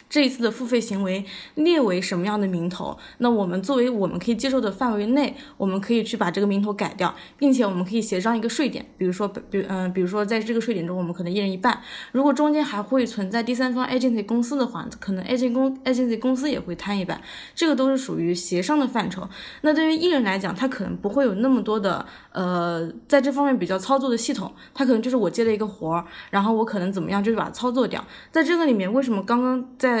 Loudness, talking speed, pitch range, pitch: -23 LUFS, 395 characters per minute, 195-260 Hz, 230 Hz